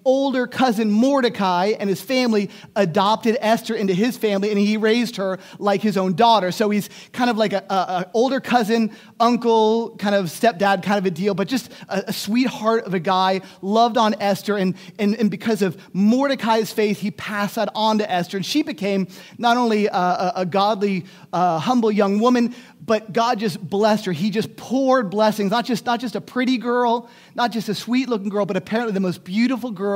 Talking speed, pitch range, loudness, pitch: 200 wpm, 195-235 Hz, -20 LUFS, 215 Hz